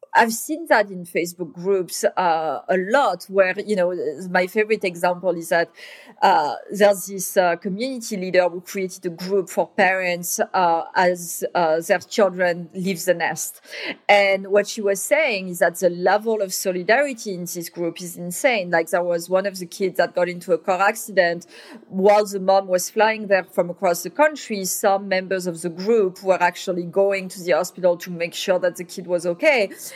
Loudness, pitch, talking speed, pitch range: -21 LUFS, 185 Hz, 190 wpm, 180-205 Hz